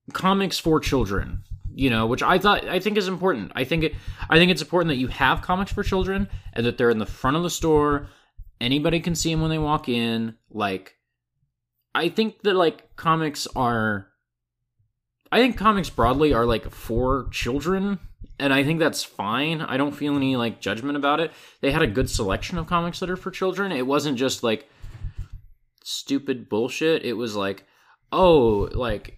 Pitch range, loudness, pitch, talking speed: 110-160 Hz, -23 LUFS, 135 Hz, 190 wpm